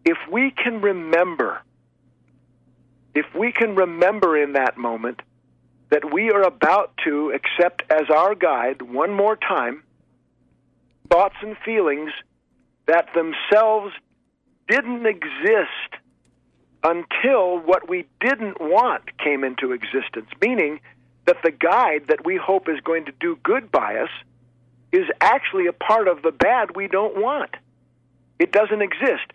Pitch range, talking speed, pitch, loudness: 135-215 Hz, 135 wpm, 175 Hz, -20 LUFS